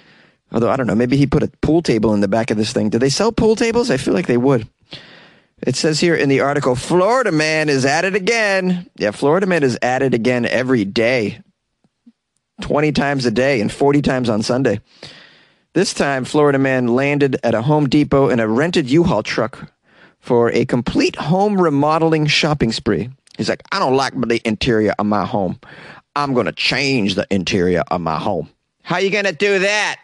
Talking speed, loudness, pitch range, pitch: 205 wpm, -16 LUFS, 120-165 Hz, 140 Hz